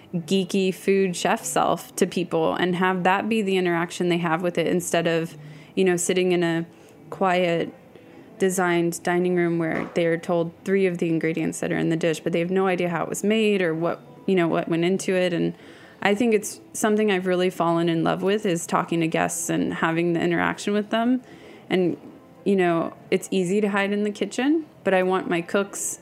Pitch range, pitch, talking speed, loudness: 170-195 Hz, 180 Hz, 215 wpm, -23 LUFS